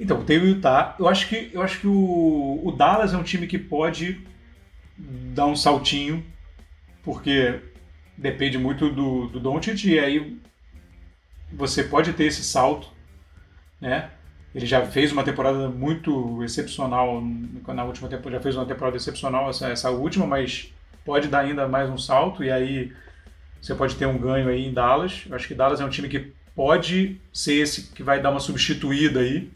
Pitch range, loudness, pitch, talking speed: 120-150 Hz, -23 LUFS, 135 Hz, 175 wpm